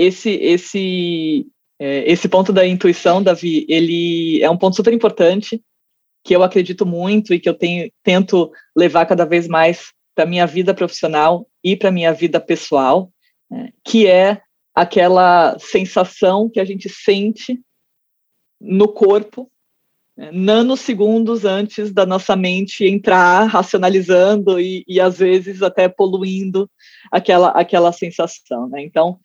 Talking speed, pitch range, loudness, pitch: 135 wpm, 175-205 Hz, -15 LUFS, 185 Hz